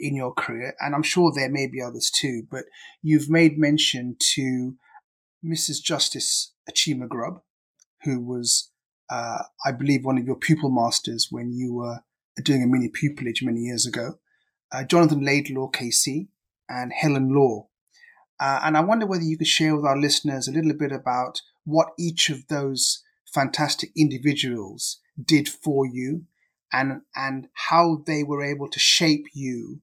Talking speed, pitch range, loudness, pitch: 160 wpm, 130-155 Hz, -23 LUFS, 140 Hz